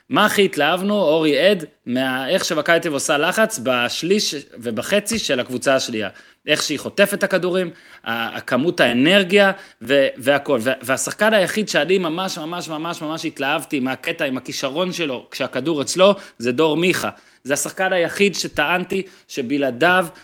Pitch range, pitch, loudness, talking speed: 145-195 Hz, 170 Hz, -19 LUFS, 135 wpm